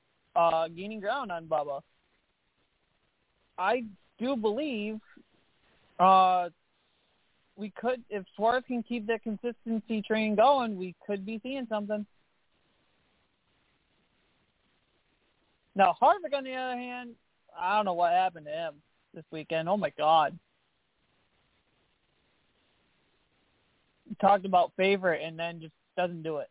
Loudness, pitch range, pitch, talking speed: -29 LUFS, 175-240 Hz, 210 Hz, 120 wpm